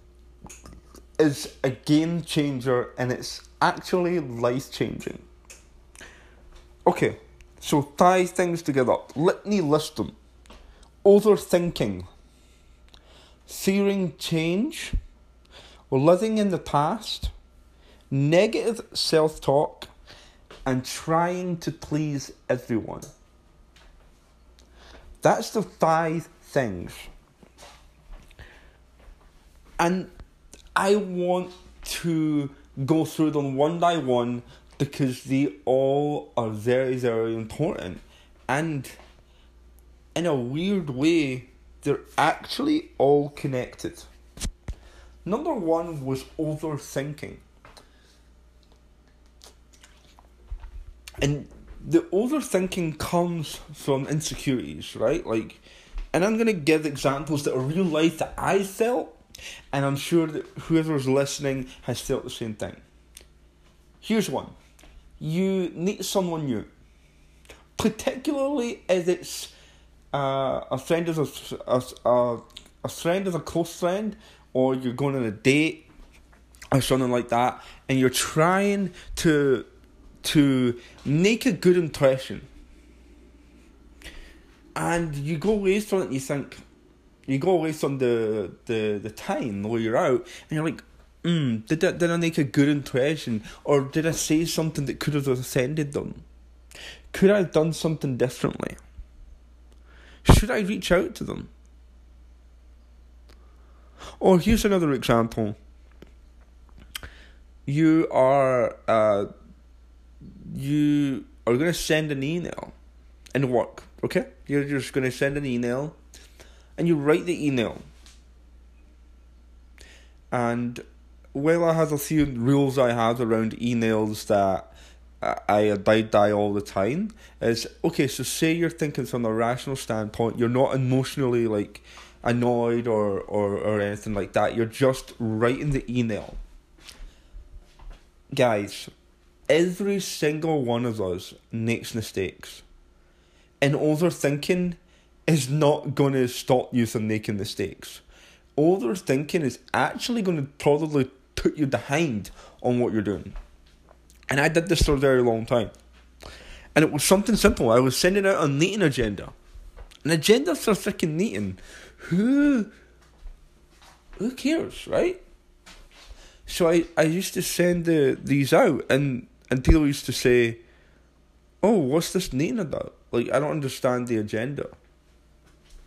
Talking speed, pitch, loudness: 120 wpm, 130 Hz, -24 LUFS